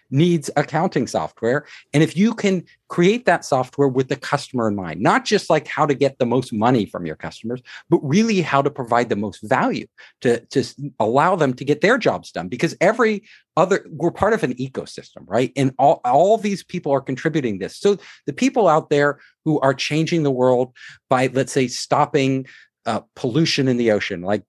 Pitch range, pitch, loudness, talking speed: 130-170 Hz, 145 Hz, -20 LUFS, 200 wpm